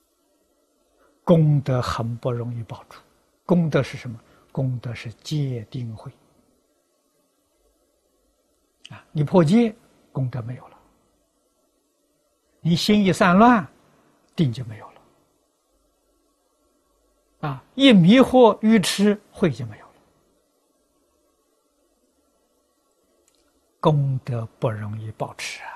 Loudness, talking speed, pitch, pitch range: -20 LUFS, 135 characters per minute, 140 Hz, 125-200 Hz